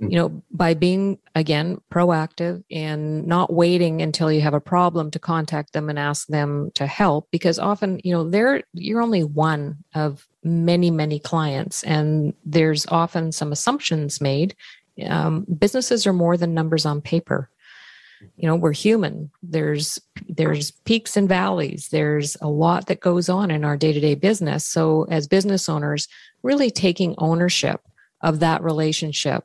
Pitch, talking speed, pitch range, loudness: 165 Hz, 155 wpm, 155-180 Hz, -21 LUFS